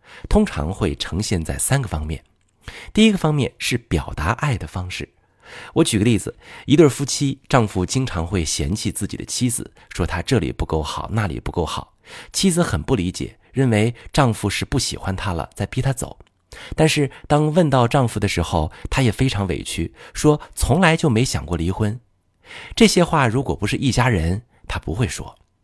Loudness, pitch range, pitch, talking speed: -20 LUFS, 90-135 Hz, 105 Hz, 265 characters per minute